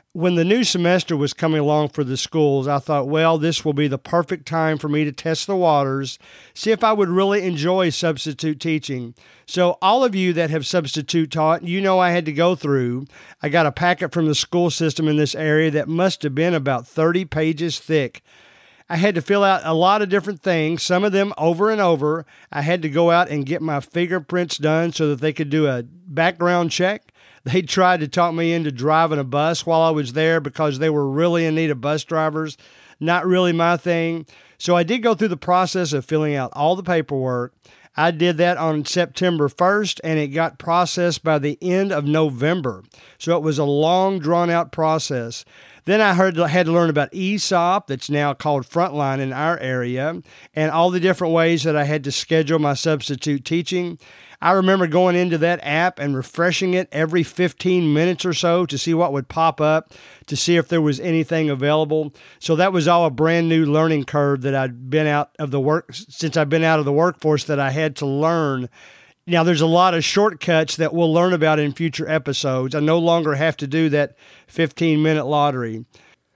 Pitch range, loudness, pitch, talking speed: 150-175 Hz, -19 LUFS, 160 Hz, 210 wpm